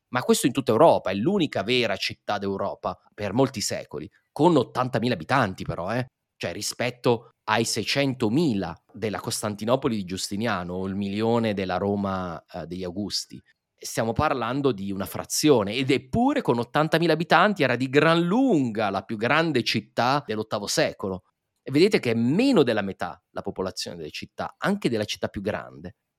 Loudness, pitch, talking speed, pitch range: -24 LUFS, 115 Hz, 160 wpm, 100-135 Hz